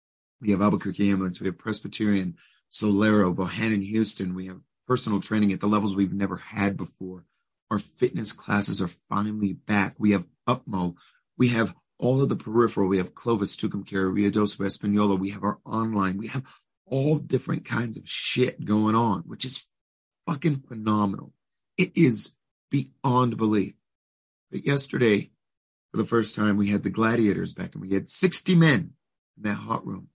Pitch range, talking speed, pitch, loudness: 100-115 Hz, 170 wpm, 105 Hz, -24 LUFS